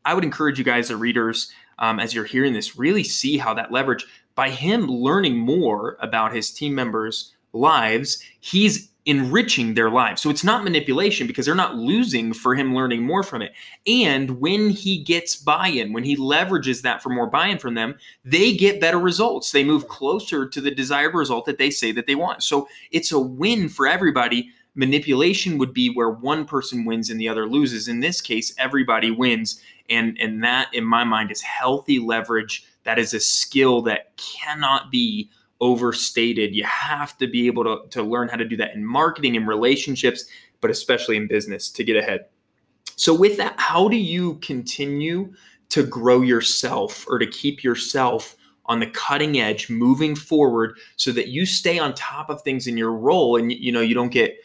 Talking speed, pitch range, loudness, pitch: 190 wpm, 120-165 Hz, -20 LUFS, 135 Hz